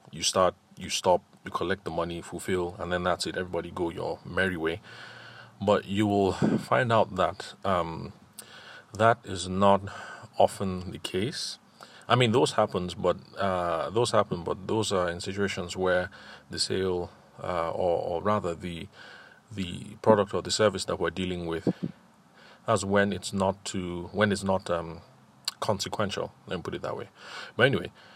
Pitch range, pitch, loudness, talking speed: 85-100 Hz, 95 Hz, -28 LUFS, 170 wpm